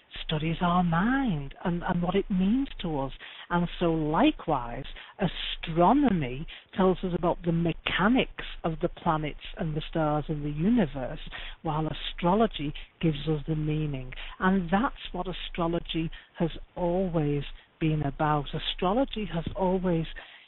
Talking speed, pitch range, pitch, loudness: 130 wpm, 155-185 Hz, 170 Hz, -28 LUFS